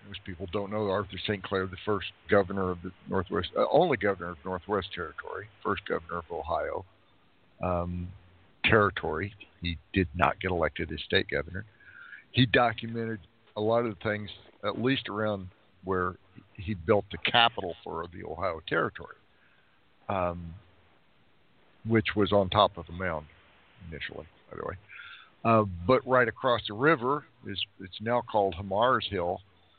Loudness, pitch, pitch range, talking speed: -29 LUFS, 100 Hz, 90-105 Hz, 155 wpm